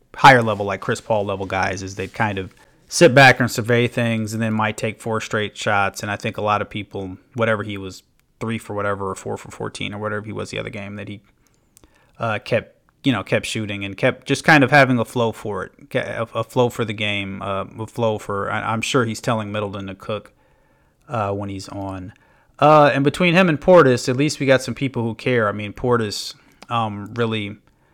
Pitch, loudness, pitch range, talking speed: 110 Hz, -19 LUFS, 100-120 Hz, 230 wpm